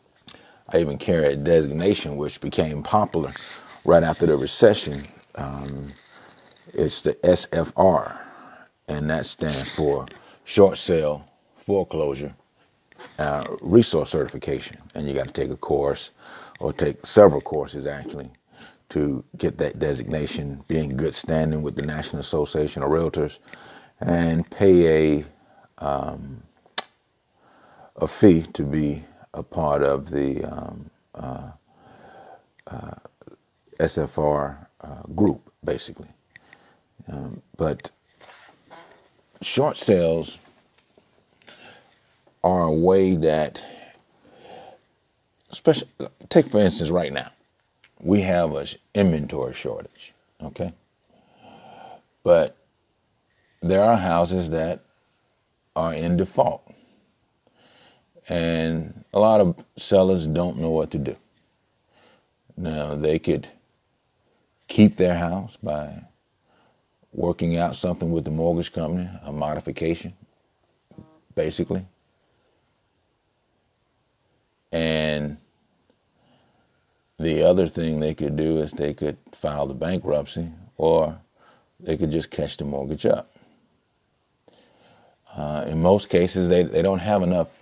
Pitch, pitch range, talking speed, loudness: 80 Hz, 75-85 Hz, 105 wpm, -23 LUFS